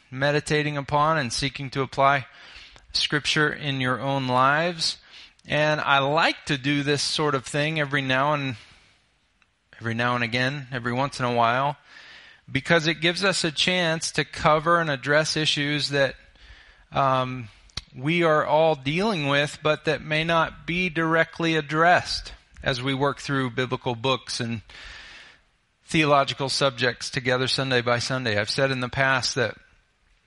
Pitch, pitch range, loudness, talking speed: 140 Hz, 130-155 Hz, -23 LUFS, 150 wpm